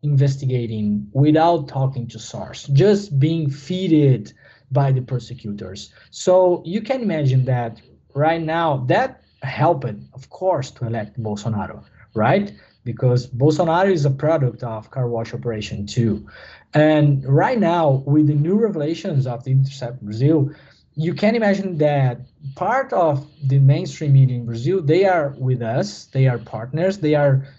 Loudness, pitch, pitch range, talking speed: -19 LUFS, 135 Hz, 120-160 Hz, 150 wpm